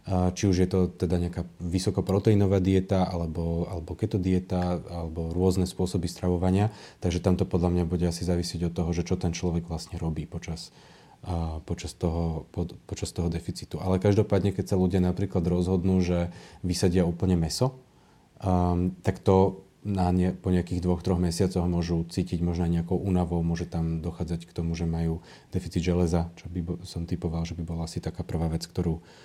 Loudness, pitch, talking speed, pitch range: -28 LUFS, 90 Hz, 175 wpm, 85-95 Hz